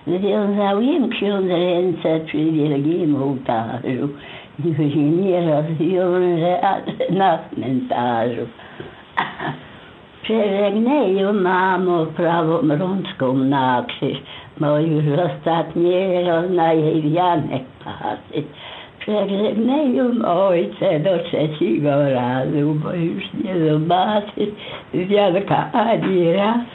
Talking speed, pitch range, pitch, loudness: 85 wpm, 150-190 Hz, 170 Hz, -19 LUFS